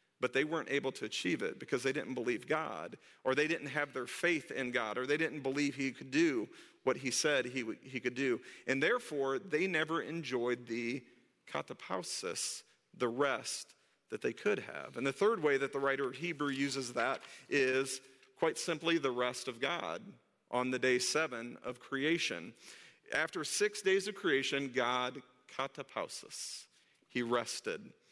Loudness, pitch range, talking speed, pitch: -36 LUFS, 125-155 Hz, 170 wpm, 135 Hz